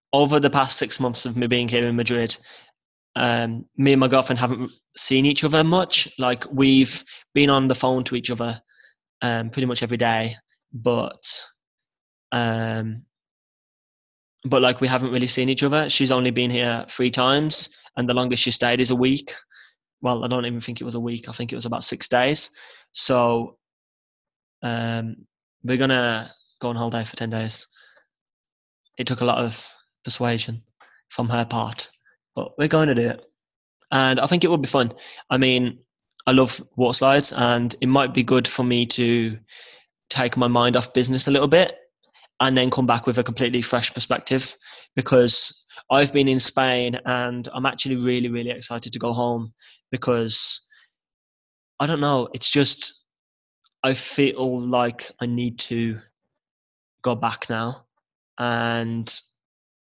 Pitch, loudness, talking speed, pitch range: 125 Hz, -20 LUFS, 170 wpm, 120-130 Hz